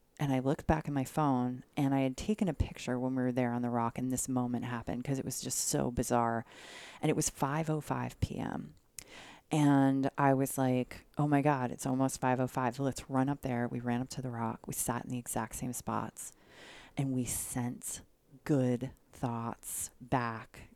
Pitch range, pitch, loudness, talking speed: 120-140 Hz, 130 Hz, -34 LUFS, 200 wpm